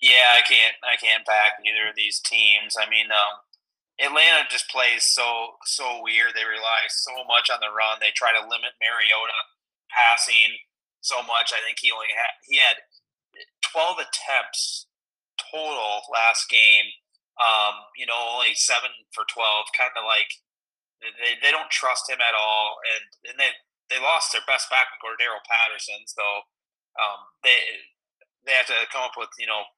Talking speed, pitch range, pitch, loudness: 170 wpm, 105-125 Hz, 115 Hz, -20 LUFS